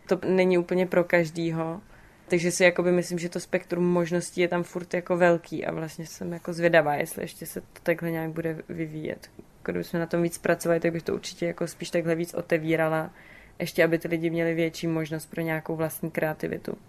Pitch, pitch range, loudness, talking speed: 170 Hz, 165-175 Hz, -27 LUFS, 195 wpm